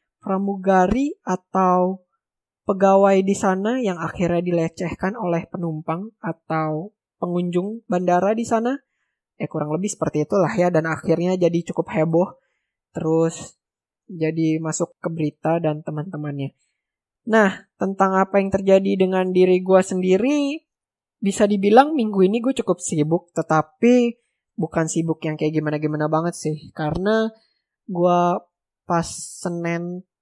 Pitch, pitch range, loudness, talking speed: 180 Hz, 160-200 Hz, -21 LUFS, 125 wpm